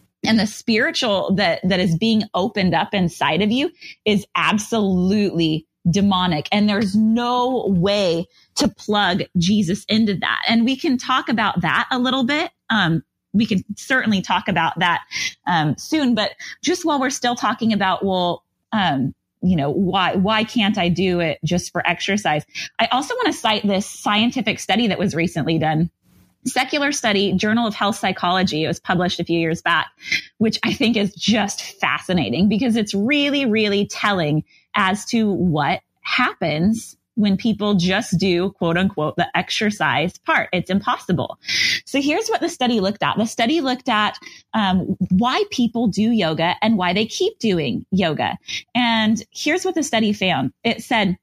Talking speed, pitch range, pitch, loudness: 165 wpm, 185-230 Hz, 210 Hz, -19 LUFS